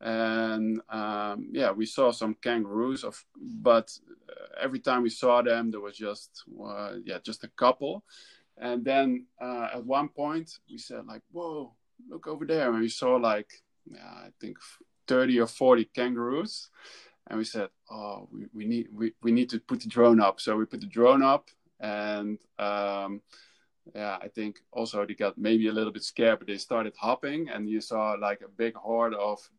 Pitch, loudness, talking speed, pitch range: 115 Hz, -28 LUFS, 185 wpm, 110-130 Hz